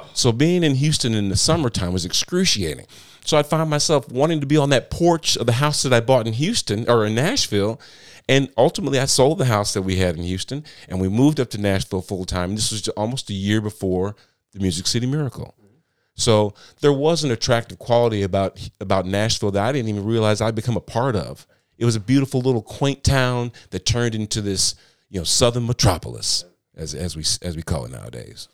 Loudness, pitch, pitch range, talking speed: -20 LUFS, 115 Hz, 100-135 Hz, 215 wpm